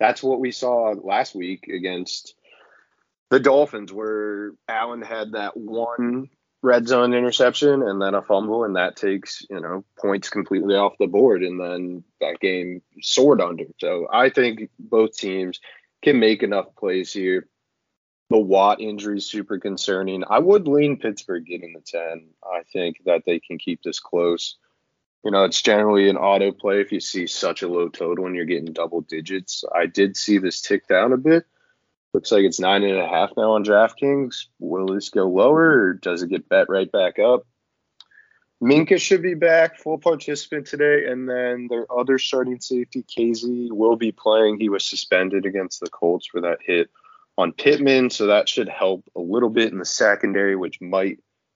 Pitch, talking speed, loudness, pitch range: 110 Hz, 185 wpm, -20 LUFS, 95-130 Hz